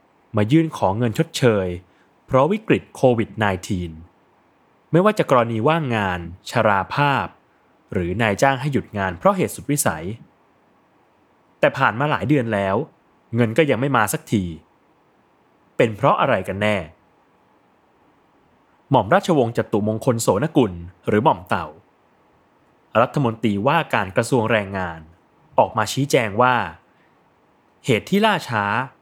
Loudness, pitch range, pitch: -20 LUFS, 95-135 Hz, 110 Hz